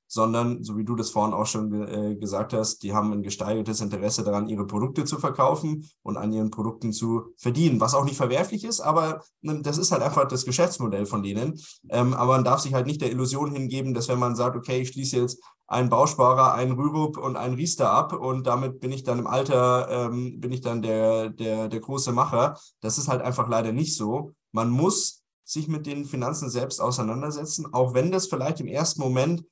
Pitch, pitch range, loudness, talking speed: 125 Hz, 110-145 Hz, -25 LUFS, 215 wpm